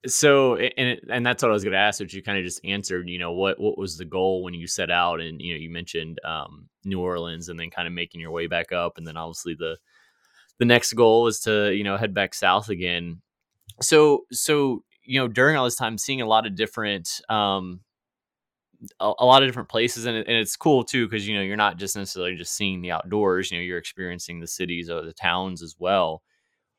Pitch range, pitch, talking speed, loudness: 85-115 Hz, 95 Hz, 240 wpm, -23 LUFS